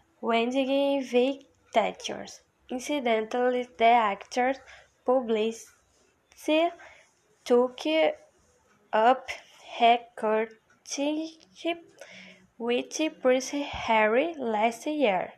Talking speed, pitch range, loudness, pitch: 60 wpm, 230-295 Hz, -27 LUFS, 255 Hz